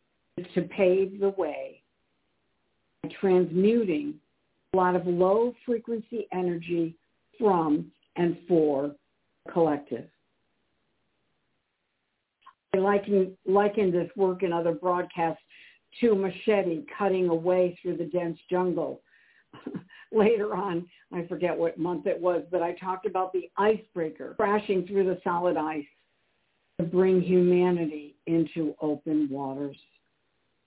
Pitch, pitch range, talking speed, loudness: 180 Hz, 165-195 Hz, 115 wpm, -27 LUFS